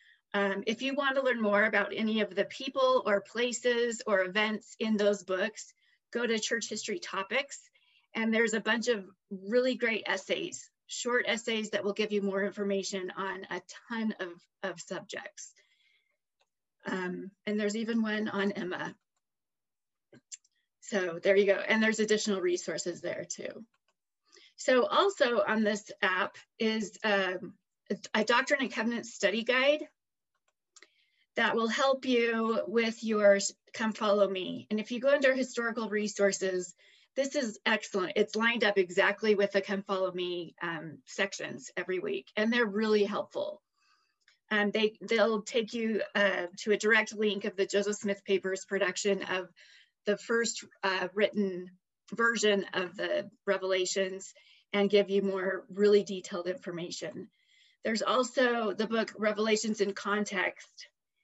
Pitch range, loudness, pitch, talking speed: 195-230 Hz, -30 LUFS, 210 Hz, 150 wpm